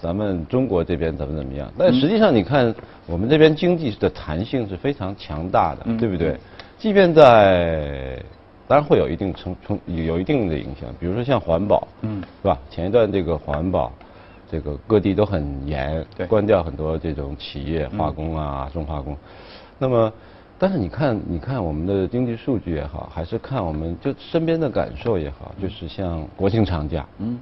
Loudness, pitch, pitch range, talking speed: -21 LUFS, 90 Hz, 80-110 Hz, 280 characters per minute